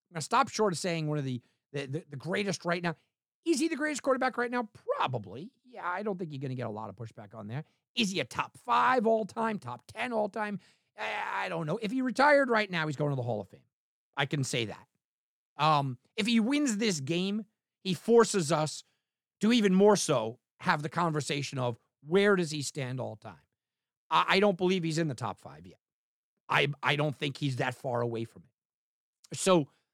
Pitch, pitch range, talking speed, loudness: 160 Hz, 130-210 Hz, 220 wpm, -30 LUFS